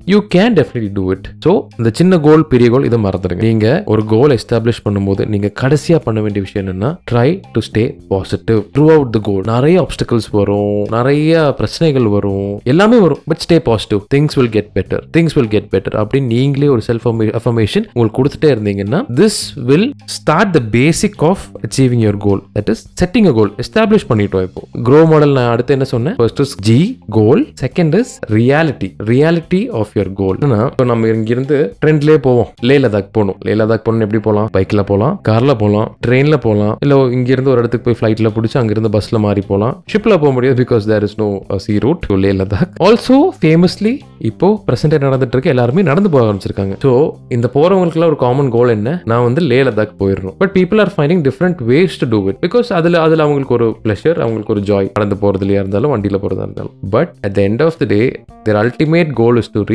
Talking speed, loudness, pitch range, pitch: 145 wpm, -13 LUFS, 105-155 Hz, 120 Hz